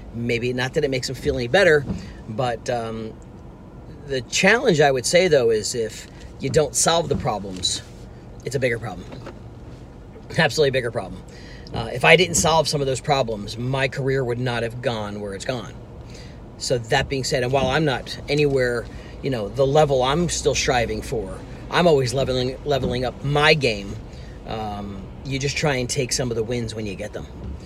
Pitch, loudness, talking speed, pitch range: 130 Hz, -21 LUFS, 190 wpm, 110-145 Hz